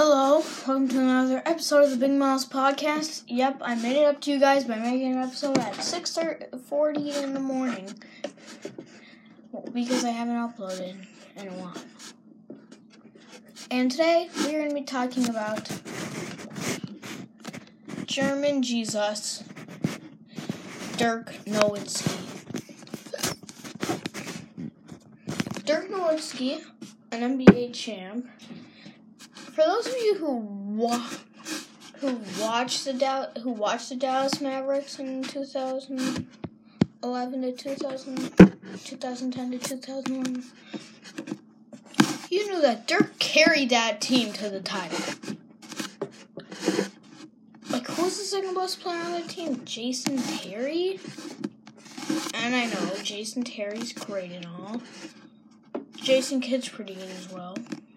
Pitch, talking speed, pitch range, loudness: 260 Hz, 115 wpm, 230-280 Hz, -26 LUFS